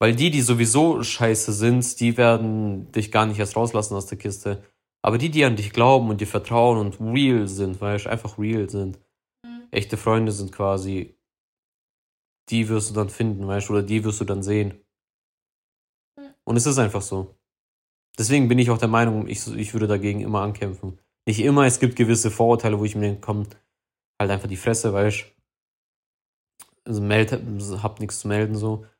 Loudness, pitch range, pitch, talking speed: -22 LUFS, 100-115 Hz, 110 Hz, 185 wpm